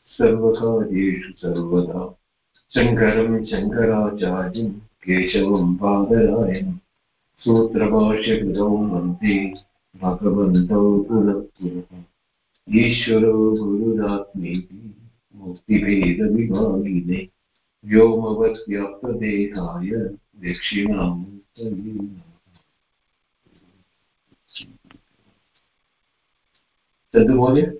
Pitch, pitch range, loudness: 100 Hz, 90-110 Hz, -20 LUFS